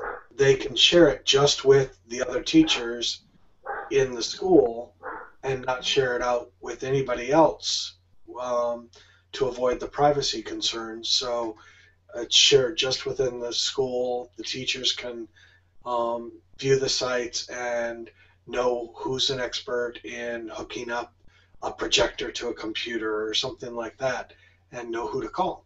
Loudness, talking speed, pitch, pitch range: -24 LUFS, 145 wpm, 125 Hz, 115-135 Hz